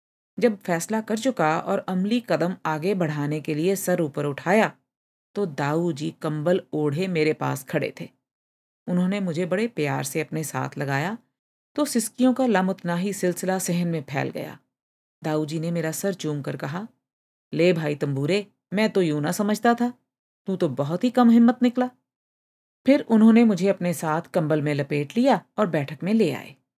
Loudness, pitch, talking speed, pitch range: -24 LUFS, 180 Hz, 180 wpm, 155-215 Hz